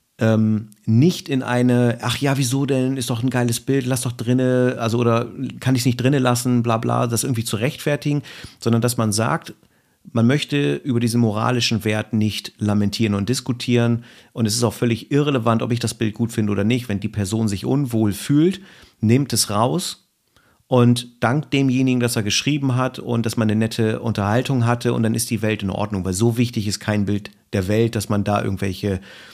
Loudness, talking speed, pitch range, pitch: -20 LUFS, 200 wpm, 110-130 Hz, 120 Hz